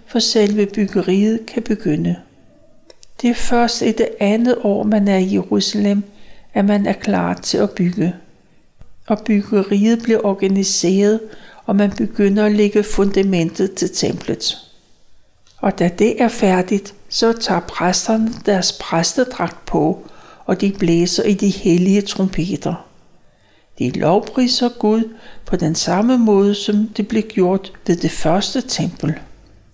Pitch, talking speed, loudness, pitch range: 205 Hz, 135 wpm, -17 LUFS, 185-220 Hz